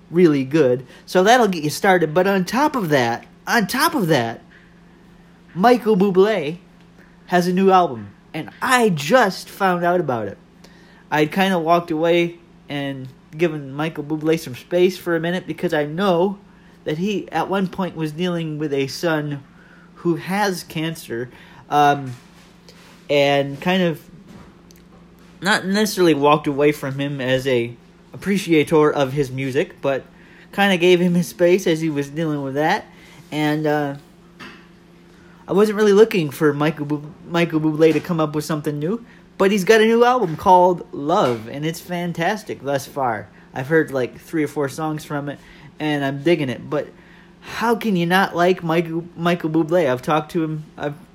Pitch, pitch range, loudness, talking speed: 170 Hz, 150-185 Hz, -19 LUFS, 170 wpm